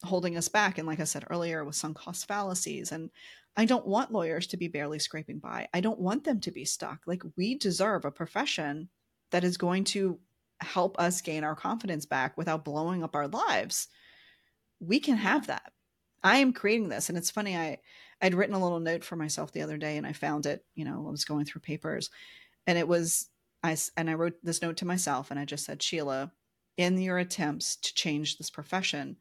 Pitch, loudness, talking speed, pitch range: 170 Hz, -31 LUFS, 215 wpm, 155-185 Hz